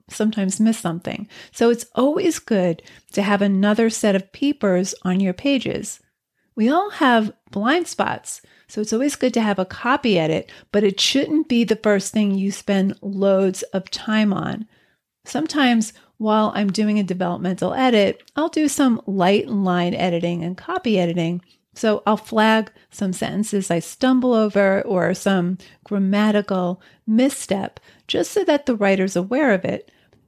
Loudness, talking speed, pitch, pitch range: -20 LUFS, 155 wpm, 210 Hz, 190-235 Hz